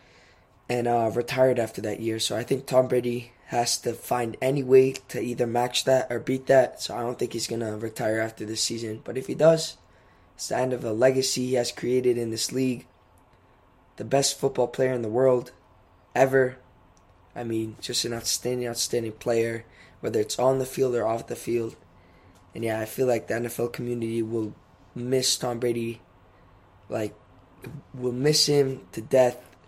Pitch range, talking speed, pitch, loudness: 110-130 Hz, 185 wpm, 120 Hz, -25 LUFS